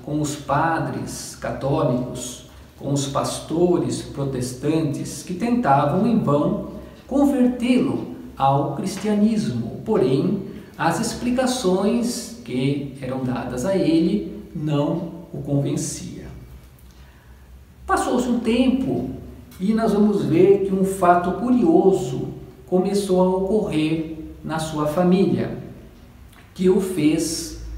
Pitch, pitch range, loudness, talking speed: 165 Hz, 140-200 Hz, -21 LUFS, 100 wpm